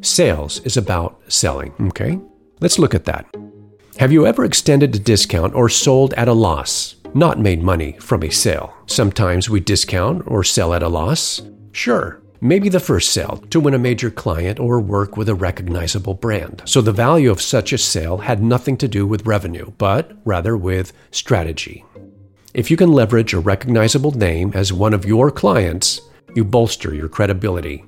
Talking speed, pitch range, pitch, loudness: 180 wpm, 95-120 Hz, 105 Hz, -16 LUFS